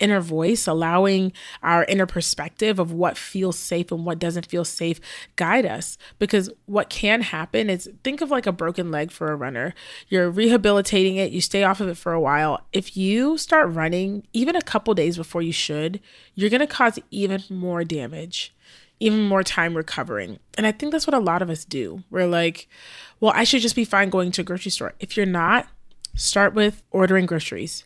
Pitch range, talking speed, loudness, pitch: 170-210 Hz, 200 wpm, -22 LUFS, 190 Hz